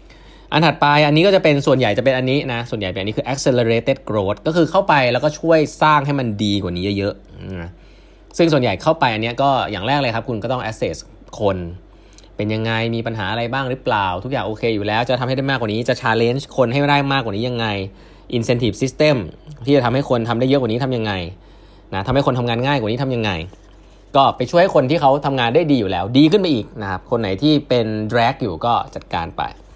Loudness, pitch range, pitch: -18 LUFS, 105-140 Hz, 125 Hz